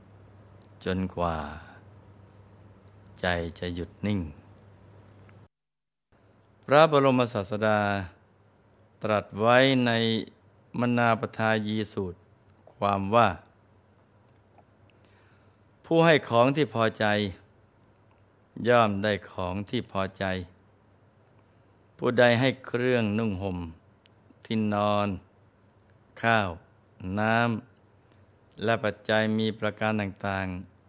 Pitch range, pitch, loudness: 100-110 Hz, 105 Hz, -26 LUFS